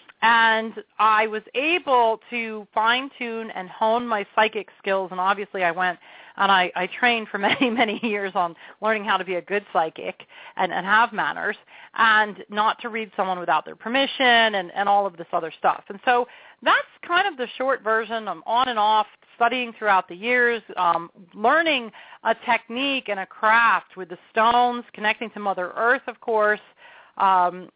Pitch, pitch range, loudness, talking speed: 220 Hz, 195-240 Hz, -22 LUFS, 175 wpm